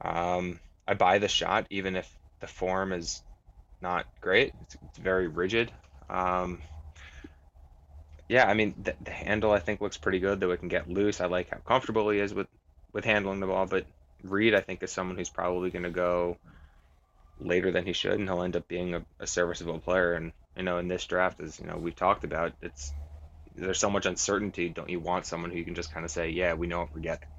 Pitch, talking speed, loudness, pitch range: 90 Hz, 225 wpm, -30 LUFS, 80-95 Hz